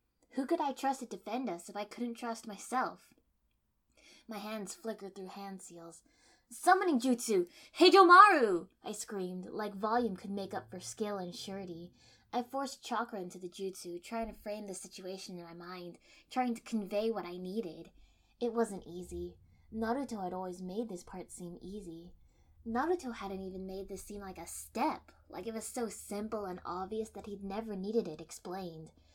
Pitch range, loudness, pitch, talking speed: 185-235 Hz, -34 LUFS, 205 Hz, 175 wpm